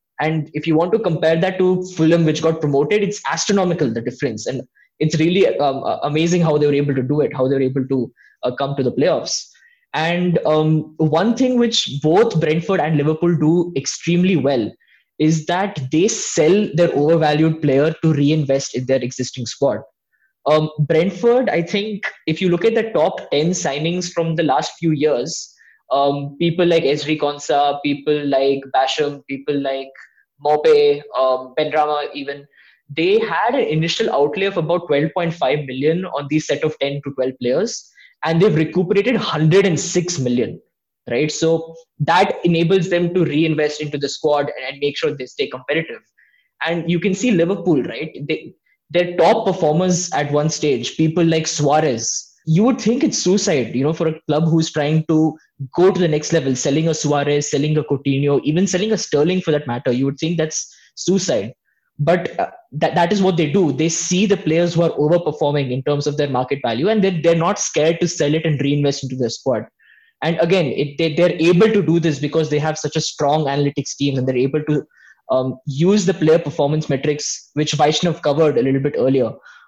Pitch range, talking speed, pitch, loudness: 145-175 Hz, 195 wpm, 155 Hz, -18 LUFS